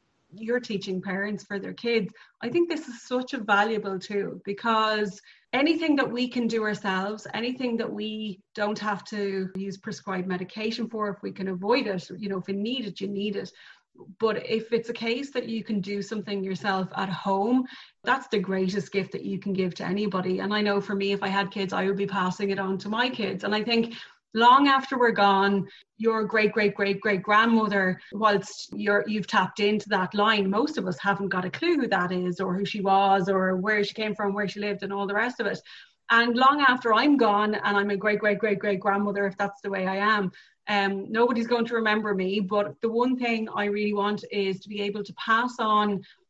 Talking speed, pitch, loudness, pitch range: 225 wpm, 205 Hz, -26 LUFS, 195-225 Hz